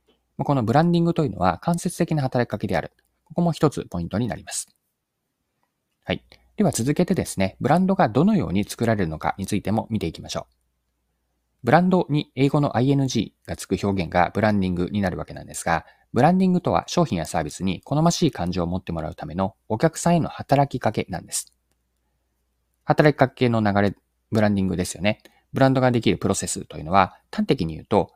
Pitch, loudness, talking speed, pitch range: 110 Hz, -23 LUFS, 425 characters per minute, 90-150 Hz